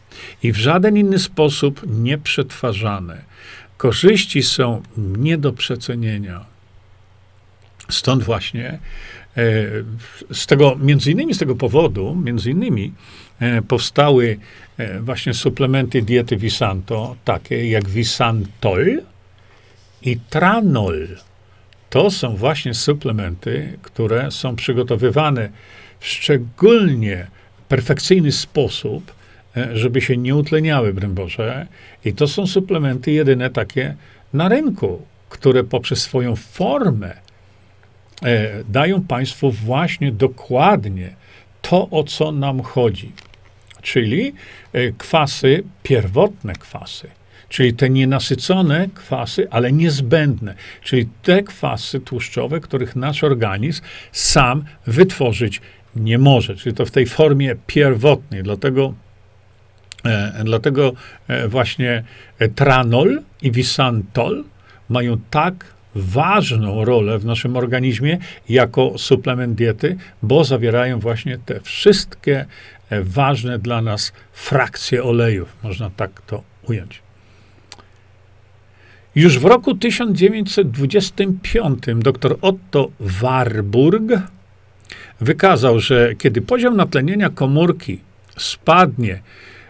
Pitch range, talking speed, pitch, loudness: 105-140 Hz, 95 wpm, 125 Hz, -17 LUFS